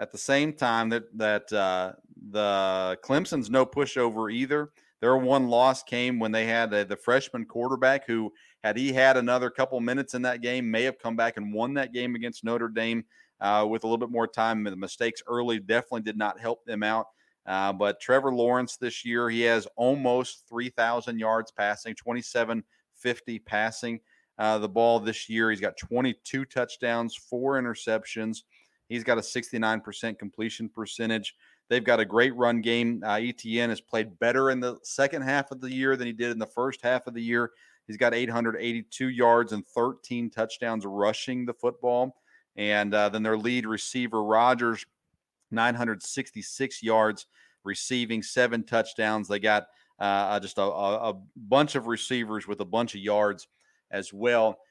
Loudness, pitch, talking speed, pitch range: -27 LUFS, 115 Hz, 175 wpm, 110-125 Hz